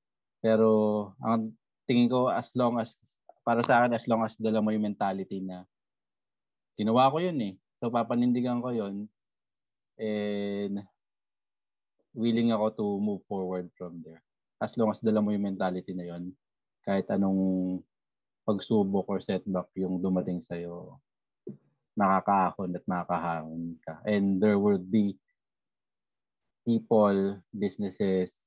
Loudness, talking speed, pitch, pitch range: -29 LUFS, 130 wpm, 100 Hz, 95-110 Hz